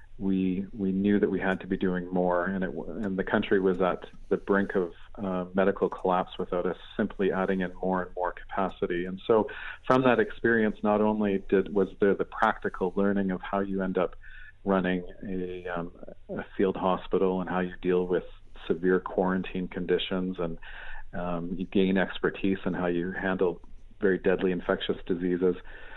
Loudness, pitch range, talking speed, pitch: -28 LUFS, 90-95 Hz, 180 wpm, 95 Hz